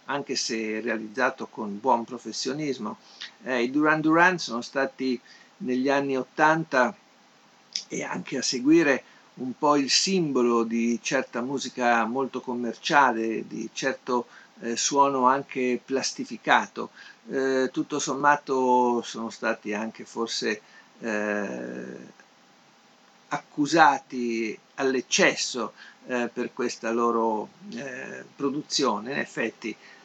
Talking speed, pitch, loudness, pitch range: 105 wpm, 125 Hz, -25 LUFS, 115-140 Hz